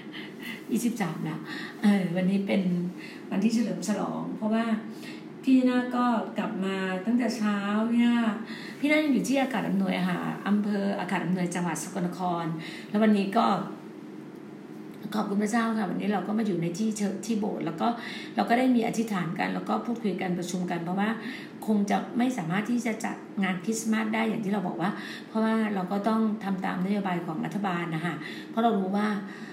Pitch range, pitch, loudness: 185-225 Hz, 205 Hz, -28 LUFS